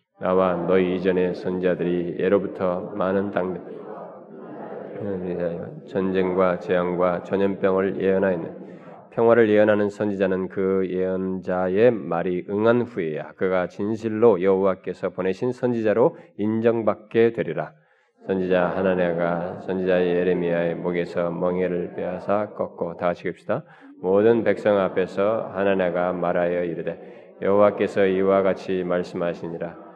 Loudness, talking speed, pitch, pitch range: -23 LUFS, 290 characters per minute, 95 Hz, 90-100 Hz